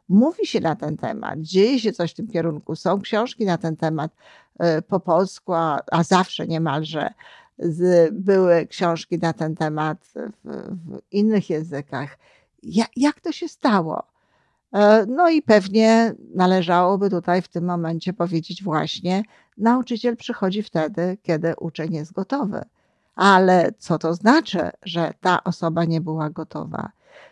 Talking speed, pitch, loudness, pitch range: 130 wpm, 180 Hz, -21 LUFS, 165-210 Hz